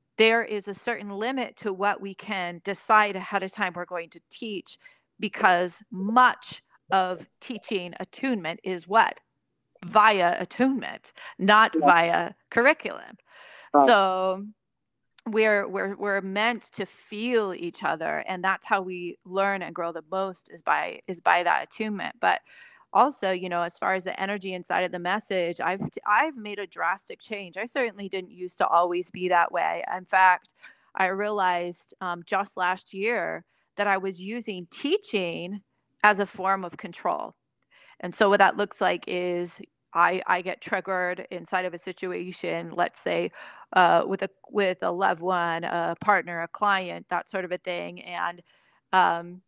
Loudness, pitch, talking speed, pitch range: -25 LUFS, 190 Hz, 160 wpm, 180-210 Hz